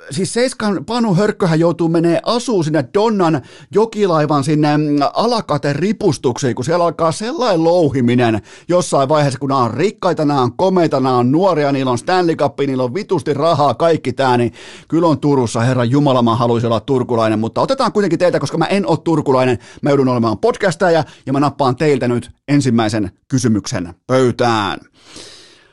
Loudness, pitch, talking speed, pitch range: -15 LUFS, 145 Hz, 165 wpm, 125-170 Hz